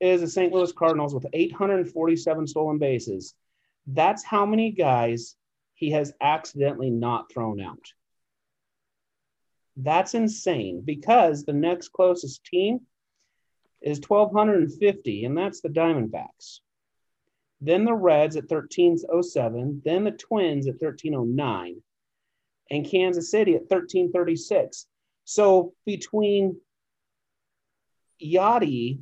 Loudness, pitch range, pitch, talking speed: -24 LUFS, 145-190 Hz, 165 Hz, 105 wpm